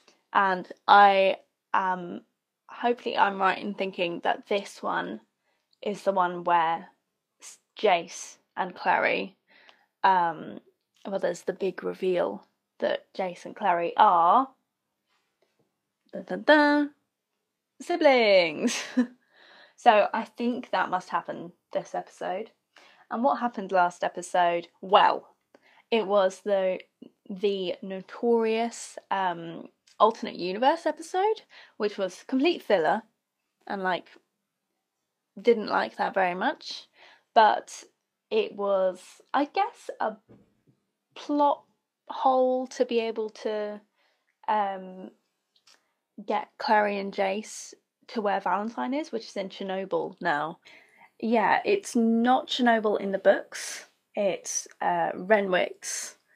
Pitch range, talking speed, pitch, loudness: 190-255 Hz, 110 wpm, 210 Hz, -26 LUFS